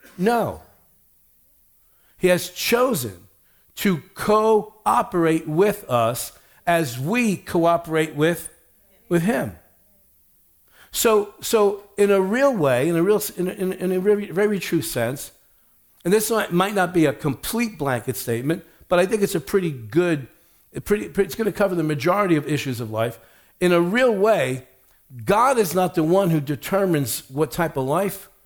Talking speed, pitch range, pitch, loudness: 160 wpm, 150-205 Hz, 175 Hz, -21 LUFS